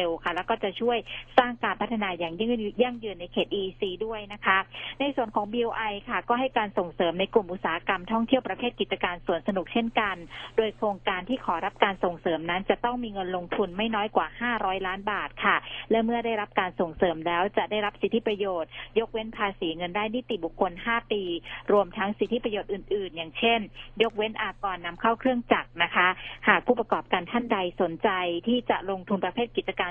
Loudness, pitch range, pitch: -27 LUFS, 185-230 Hz, 205 Hz